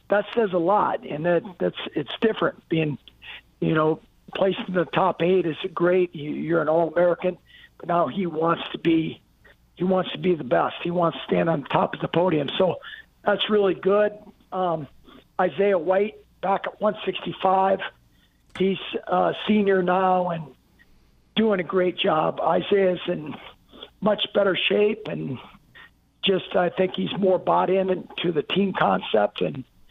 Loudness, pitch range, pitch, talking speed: -23 LUFS, 170-195 Hz, 185 Hz, 165 wpm